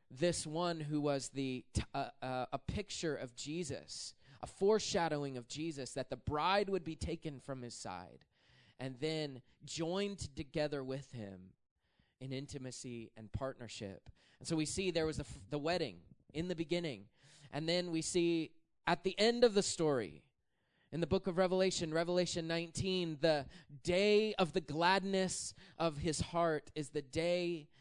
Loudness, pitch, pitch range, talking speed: -38 LUFS, 155 Hz, 135-175 Hz, 165 wpm